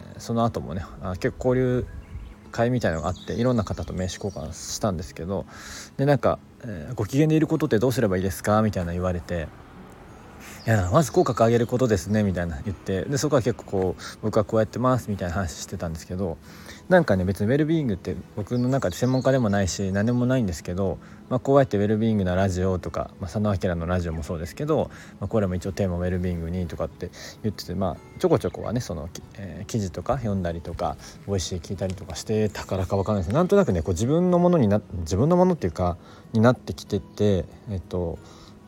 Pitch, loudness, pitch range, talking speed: 100 Hz, -25 LUFS, 90-115 Hz, 475 characters per minute